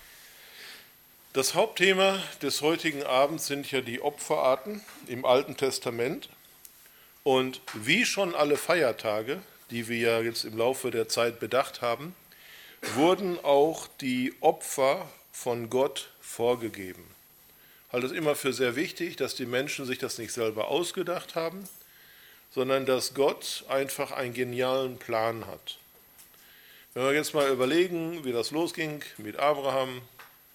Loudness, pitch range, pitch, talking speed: -28 LUFS, 125-160 Hz, 135 Hz, 135 wpm